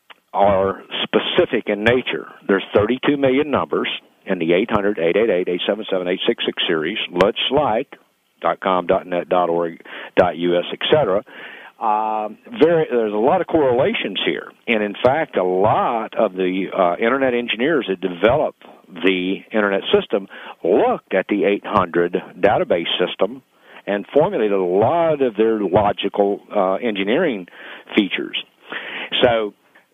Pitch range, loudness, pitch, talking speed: 95-120 Hz, -19 LUFS, 100 Hz, 120 wpm